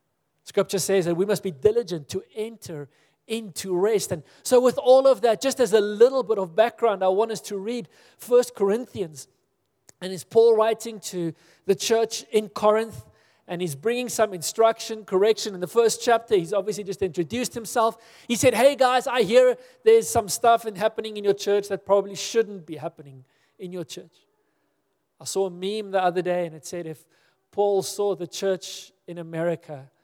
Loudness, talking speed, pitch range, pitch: -23 LUFS, 185 wpm, 180-230 Hz, 205 Hz